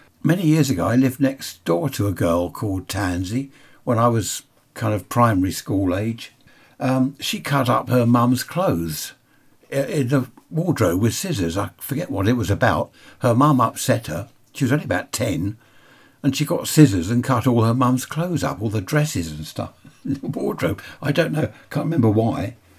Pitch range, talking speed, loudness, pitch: 105-140 Hz, 190 wpm, -21 LUFS, 125 Hz